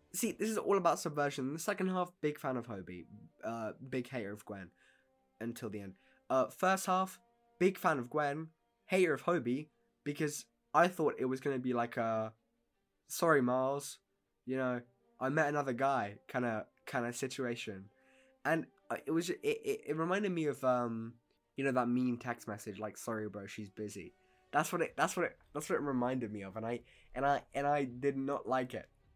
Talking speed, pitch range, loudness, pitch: 200 wpm, 115-160 Hz, -36 LUFS, 130 Hz